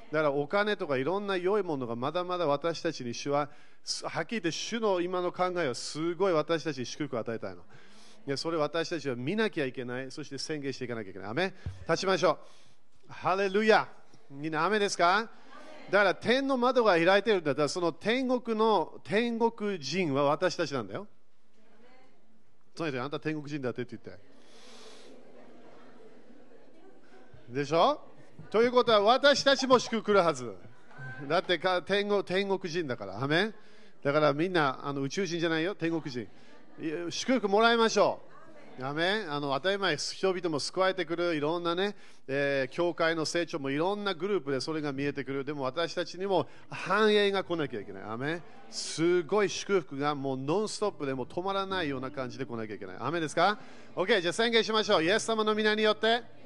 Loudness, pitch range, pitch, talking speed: -29 LUFS, 145-200 Hz, 170 Hz, 370 characters per minute